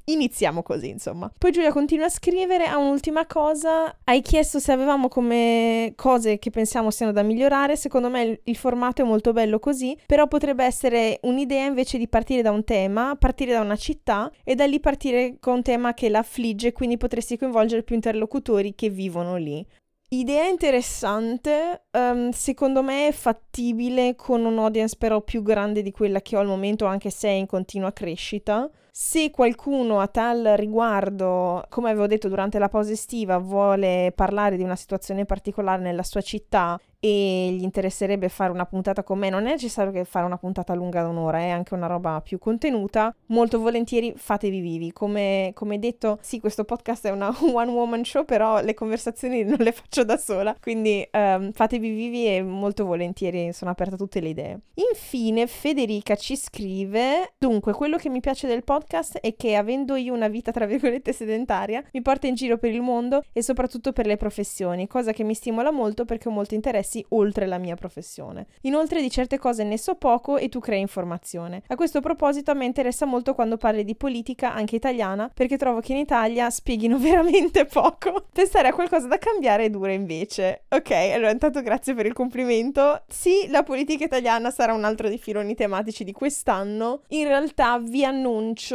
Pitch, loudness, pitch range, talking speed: 230 Hz, -23 LUFS, 205-265 Hz, 185 wpm